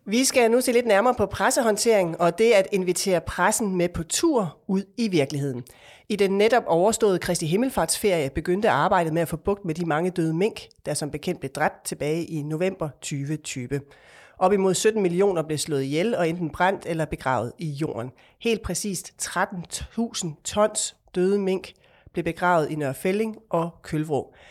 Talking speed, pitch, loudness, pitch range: 175 wpm, 180 Hz, -24 LUFS, 155-200 Hz